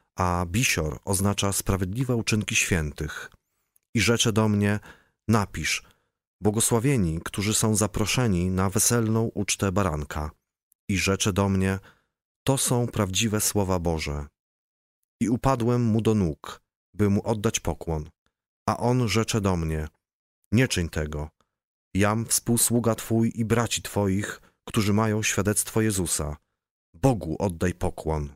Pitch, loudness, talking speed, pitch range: 100 Hz, -25 LUFS, 125 wpm, 90-115 Hz